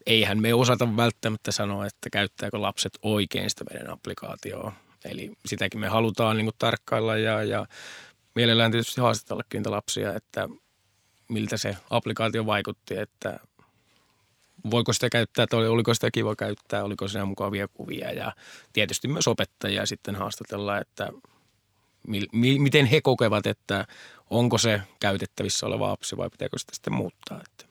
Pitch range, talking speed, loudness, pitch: 100-115 Hz, 145 wpm, -26 LUFS, 110 Hz